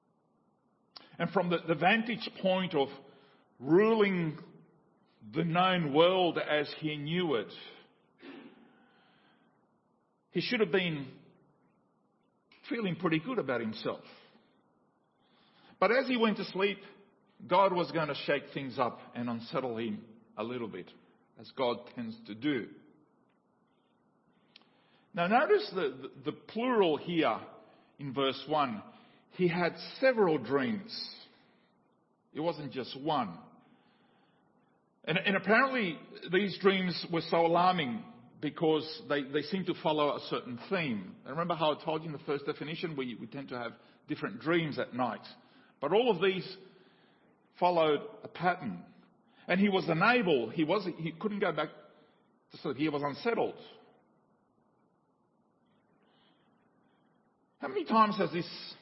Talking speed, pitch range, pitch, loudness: 135 wpm, 150-220 Hz, 180 Hz, -32 LUFS